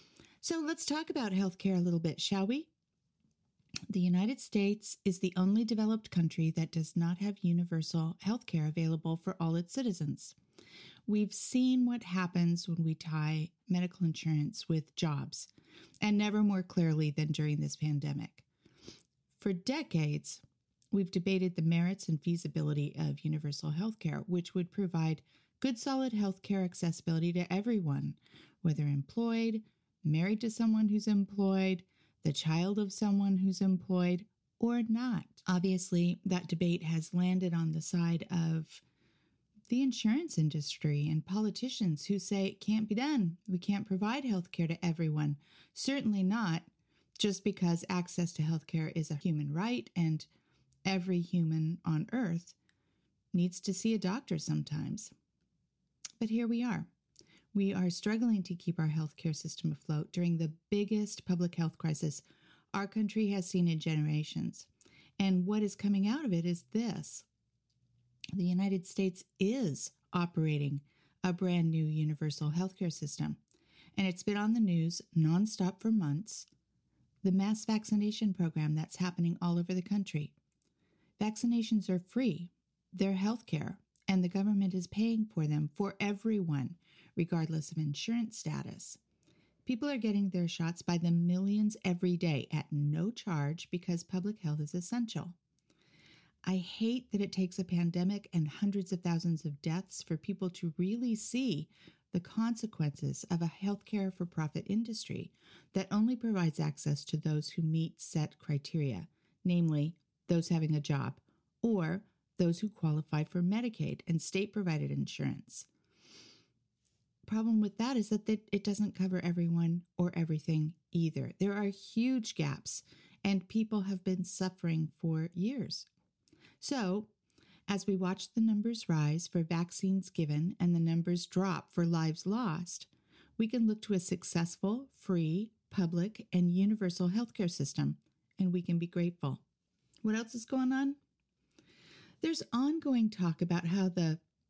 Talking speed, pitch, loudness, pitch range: 145 wpm, 180 Hz, -34 LUFS, 160-205 Hz